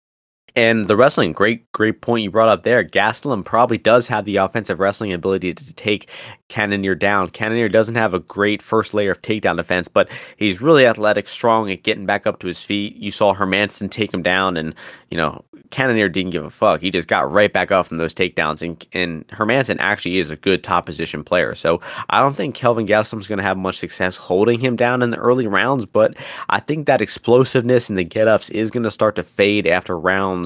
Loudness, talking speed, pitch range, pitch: -18 LUFS, 220 wpm, 95-110 Hz, 105 Hz